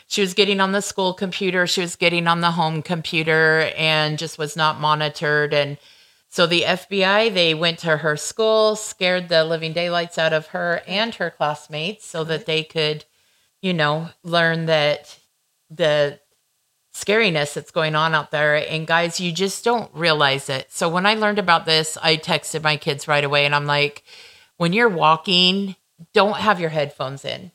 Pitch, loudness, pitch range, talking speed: 165 Hz, -19 LUFS, 155-190 Hz, 180 wpm